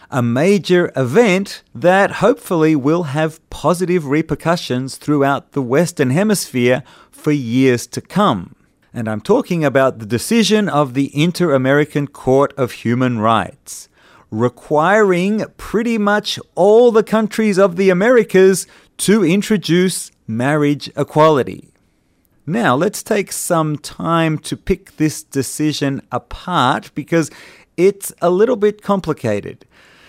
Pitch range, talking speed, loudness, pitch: 135-190 Hz, 120 wpm, -16 LUFS, 155 Hz